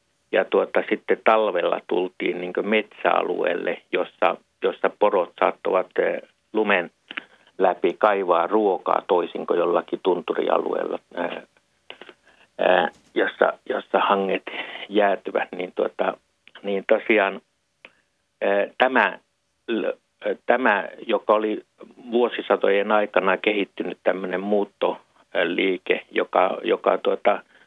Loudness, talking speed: -23 LUFS, 85 wpm